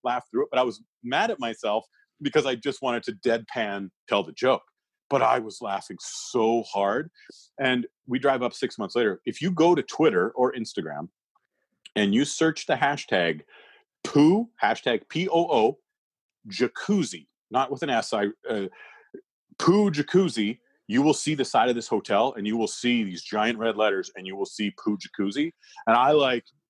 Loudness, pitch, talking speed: -25 LUFS, 145 Hz, 180 wpm